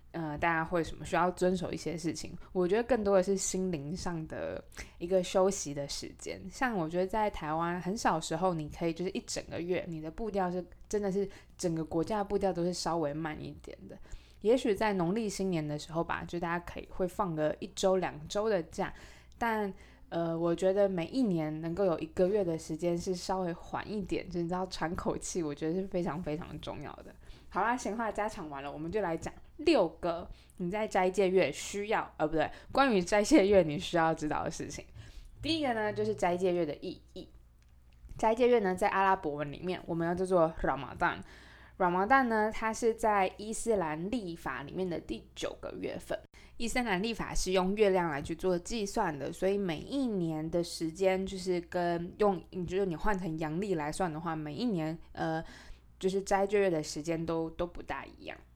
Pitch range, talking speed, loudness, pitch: 165-200 Hz, 310 characters per minute, -33 LUFS, 180 Hz